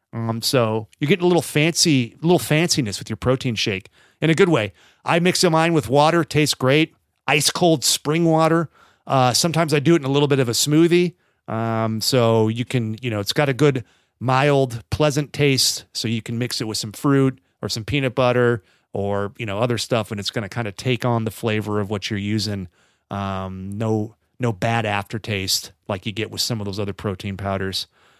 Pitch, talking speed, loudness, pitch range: 120 Hz, 210 wpm, -20 LUFS, 105-150 Hz